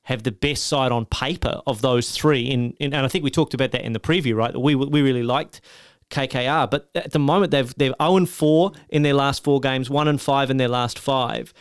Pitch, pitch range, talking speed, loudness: 140 Hz, 125-150 Hz, 245 wpm, -21 LUFS